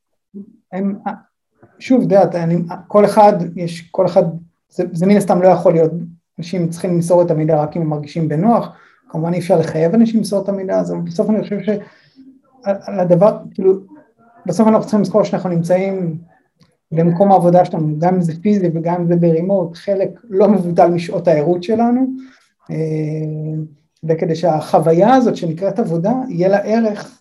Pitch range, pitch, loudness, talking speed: 170-205 Hz, 185 Hz, -15 LUFS, 155 wpm